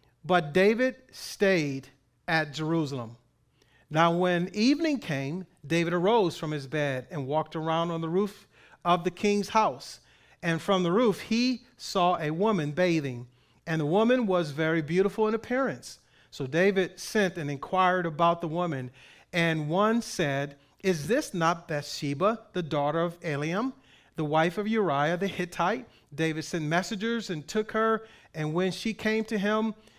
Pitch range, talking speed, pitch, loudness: 155-210 Hz, 155 wpm, 175 Hz, -28 LUFS